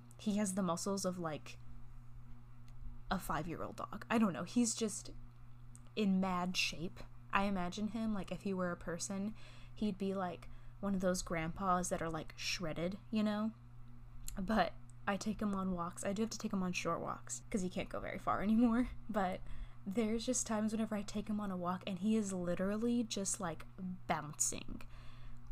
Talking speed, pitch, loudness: 190 wpm, 180 Hz, -38 LUFS